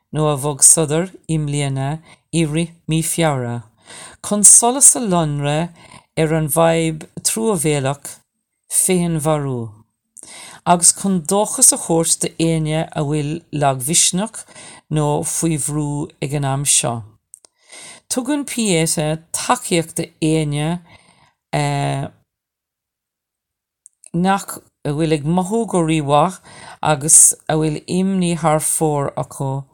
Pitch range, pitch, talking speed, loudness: 150-175 Hz, 160 Hz, 110 wpm, -16 LUFS